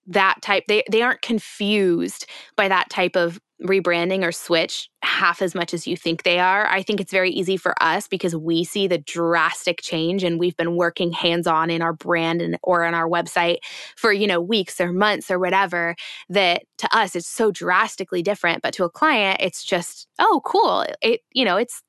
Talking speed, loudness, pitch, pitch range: 210 wpm, -20 LUFS, 180 Hz, 170-195 Hz